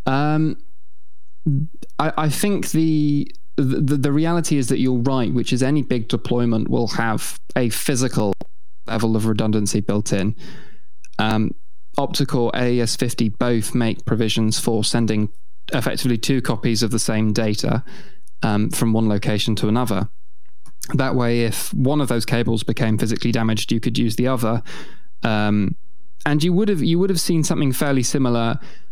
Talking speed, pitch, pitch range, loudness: 155 wpm, 120 Hz, 110-145 Hz, -20 LUFS